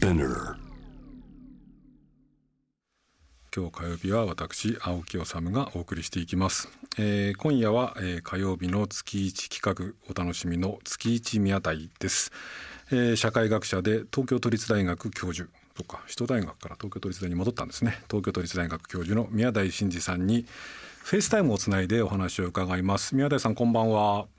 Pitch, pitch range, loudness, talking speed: 100 Hz, 90-115 Hz, -28 LUFS, 300 characters per minute